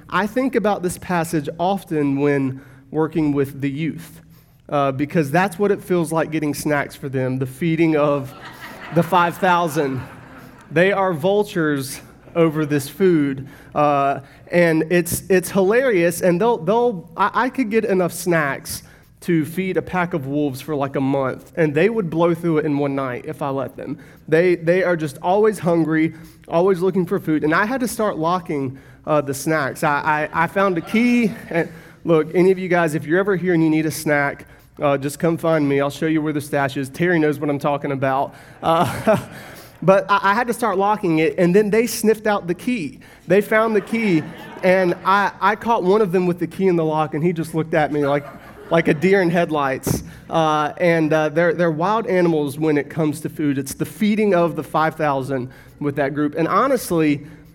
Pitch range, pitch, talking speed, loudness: 145-185 Hz, 160 Hz, 210 wpm, -19 LUFS